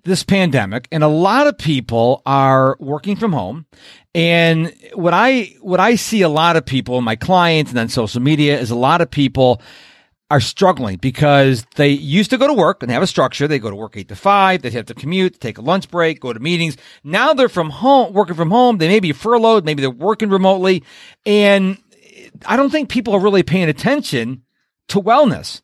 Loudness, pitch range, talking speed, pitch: -15 LUFS, 135-200 Hz, 210 wpm, 170 Hz